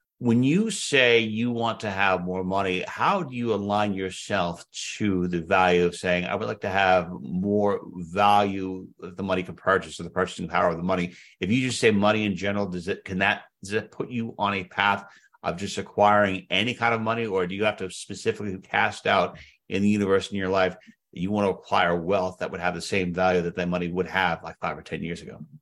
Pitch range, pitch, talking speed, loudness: 90-105 Hz, 100 Hz, 235 wpm, -25 LUFS